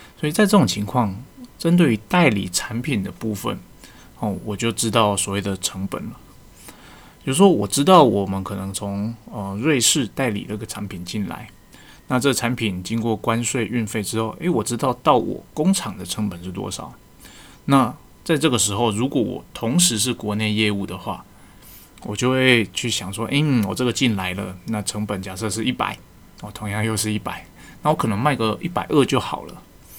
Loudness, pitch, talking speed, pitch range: -21 LUFS, 110 Hz, 270 characters per minute, 100-125 Hz